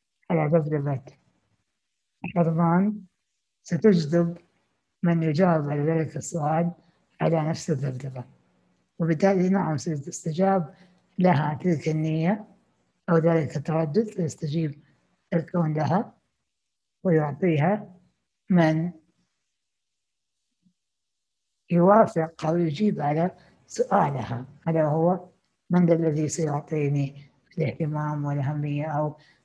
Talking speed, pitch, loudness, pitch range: 80 wpm, 160 Hz, -25 LUFS, 150-175 Hz